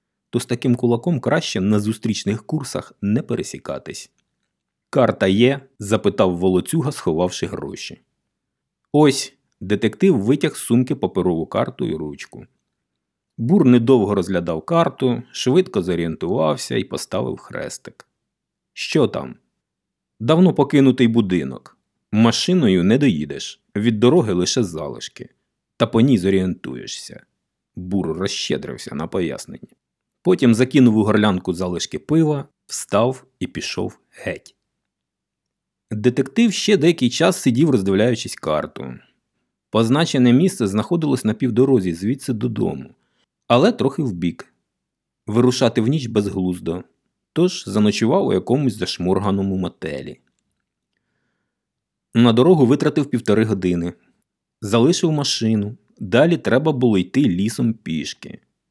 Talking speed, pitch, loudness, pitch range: 105 wpm, 120 Hz, -19 LUFS, 95-135 Hz